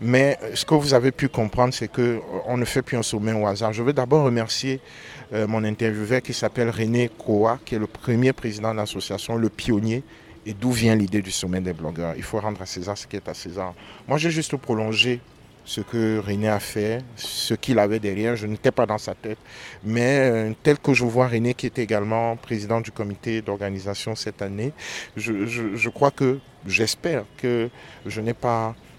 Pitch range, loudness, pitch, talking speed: 105-125 Hz, -23 LUFS, 115 Hz, 200 wpm